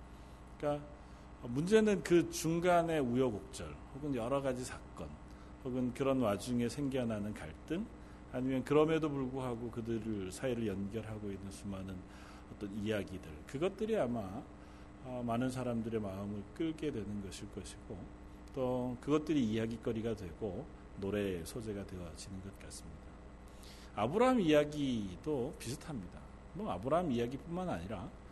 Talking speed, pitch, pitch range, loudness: 310 characters per minute, 110 Hz, 100-135 Hz, -37 LUFS